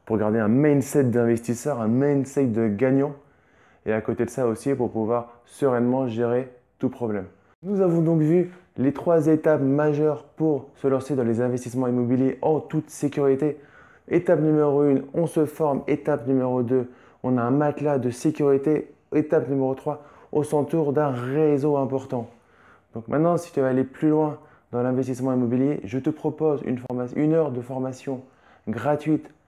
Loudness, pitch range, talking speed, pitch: -23 LUFS, 125-150 Hz, 170 wpm, 135 Hz